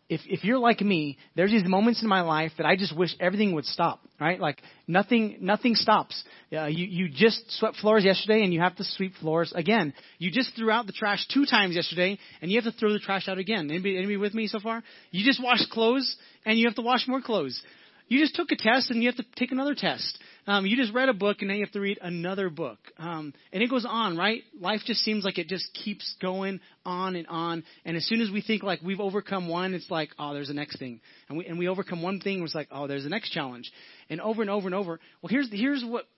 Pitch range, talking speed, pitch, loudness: 175-225 Hz, 260 wpm, 195 Hz, -27 LUFS